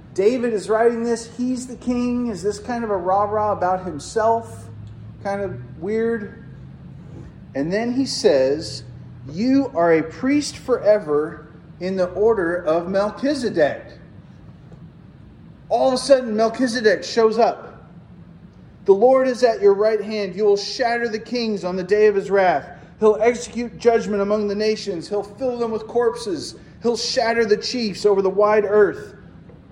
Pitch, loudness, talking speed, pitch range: 215 Hz, -20 LUFS, 155 wpm, 195-235 Hz